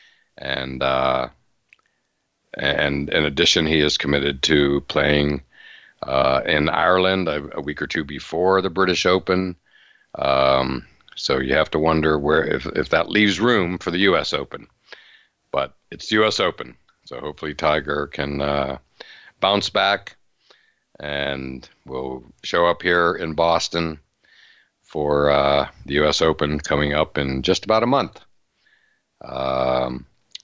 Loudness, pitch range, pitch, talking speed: -20 LUFS, 70-85 Hz, 75 Hz, 135 wpm